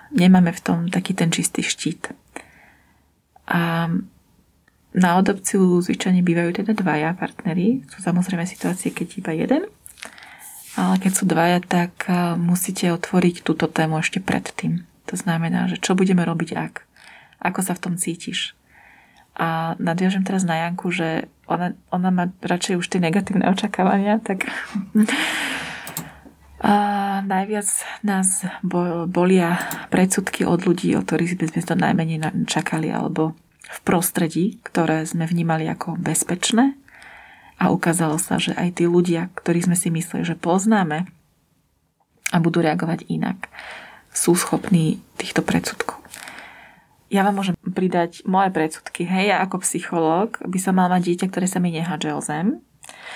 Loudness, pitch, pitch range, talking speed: -21 LUFS, 180 Hz, 170-195 Hz, 140 wpm